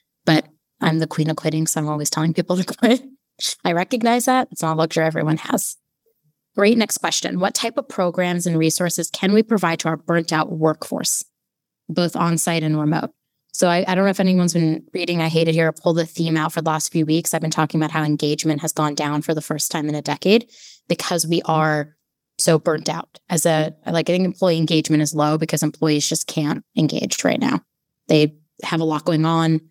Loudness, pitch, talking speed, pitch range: -20 LUFS, 160 Hz, 220 wpm, 155-175 Hz